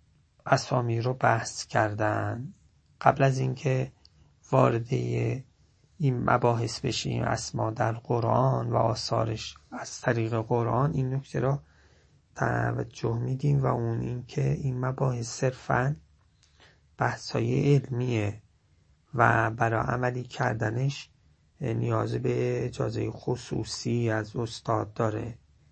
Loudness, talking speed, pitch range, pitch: -28 LUFS, 100 wpm, 105-130 Hz, 115 Hz